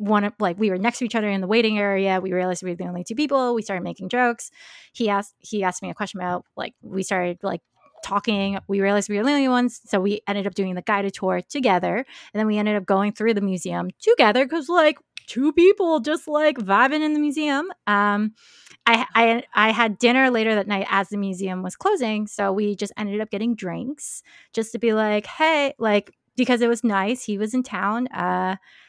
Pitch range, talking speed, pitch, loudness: 195-245 Hz, 230 wpm, 210 Hz, -22 LUFS